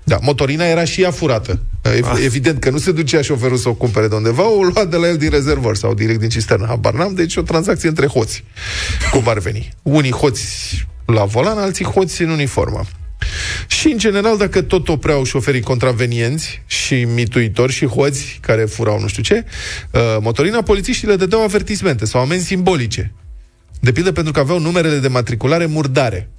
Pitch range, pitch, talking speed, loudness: 115-170 Hz, 135 Hz, 180 wpm, -16 LUFS